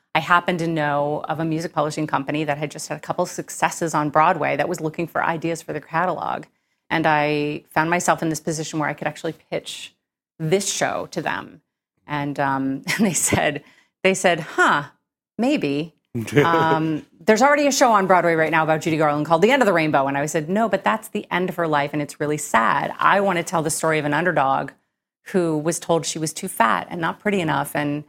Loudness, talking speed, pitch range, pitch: -21 LUFS, 225 wpm, 150-180 Hz, 160 Hz